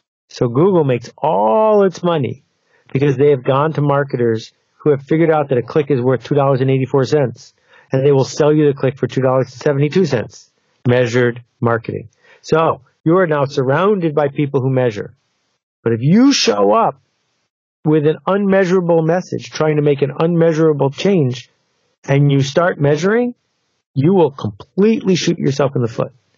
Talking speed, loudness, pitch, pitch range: 155 wpm, -15 LUFS, 145 Hz, 130-165 Hz